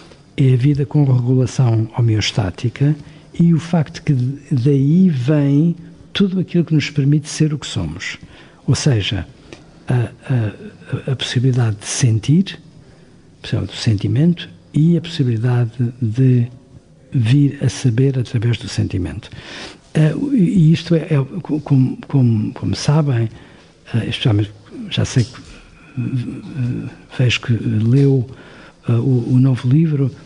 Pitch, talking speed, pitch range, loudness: 135 Hz, 120 wpm, 120-150 Hz, -17 LUFS